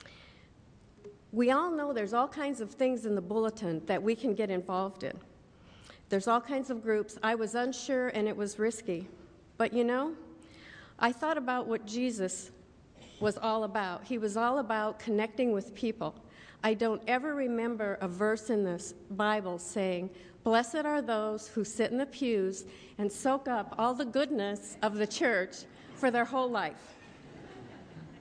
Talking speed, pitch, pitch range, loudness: 165 wpm, 220 Hz, 210-250 Hz, -32 LUFS